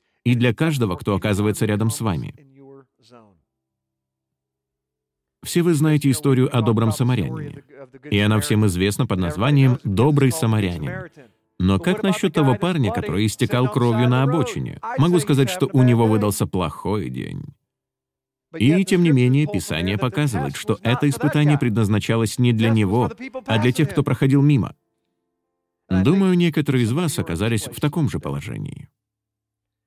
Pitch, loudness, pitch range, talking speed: 120 Hz, -20 LUFS, 105-145 Hz, 140 wpm